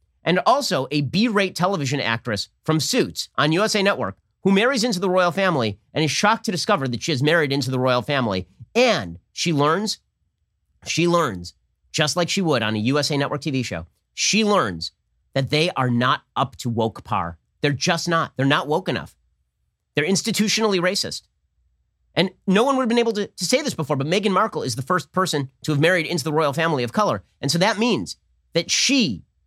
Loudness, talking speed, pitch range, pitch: -21 LUFS, 205 wpm, 120-185 Hz, 150 Hz